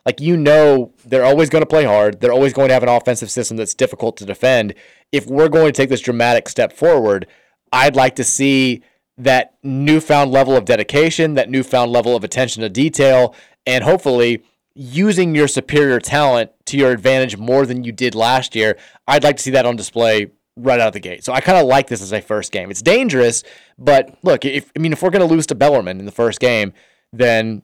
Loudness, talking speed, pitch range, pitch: -15 LUFS, 220 wpm, 120-145 Hz, 130 Hz